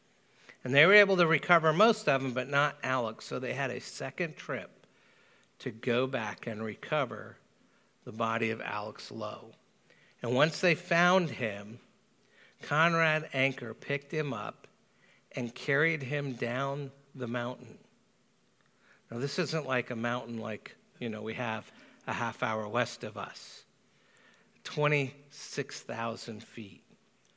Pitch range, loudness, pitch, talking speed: 115-150 Hz, -31 LUFS, 130 Hz, 140 wpm